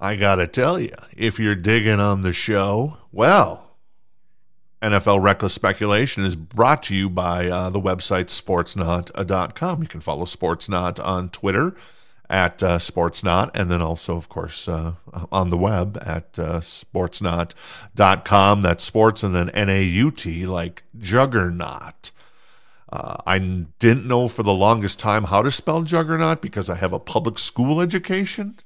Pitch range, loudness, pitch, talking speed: 90-115 Hz, -20 LUFS, 100 Hz, 145 wpm